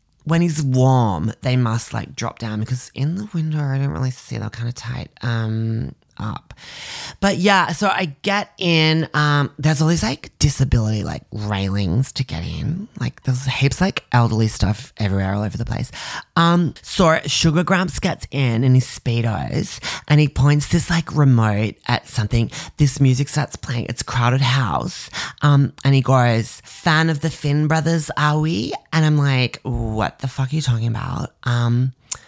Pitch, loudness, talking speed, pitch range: 135 Hz, -19 LUFS, 180 wpm, 115-155 Hz